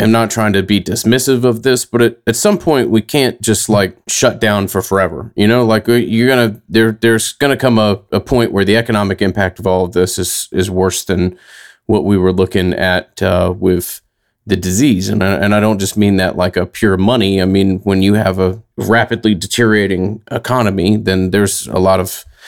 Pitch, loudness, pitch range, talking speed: 105 Hz, -13 LUFS, 95-115 Hz, 215 wpm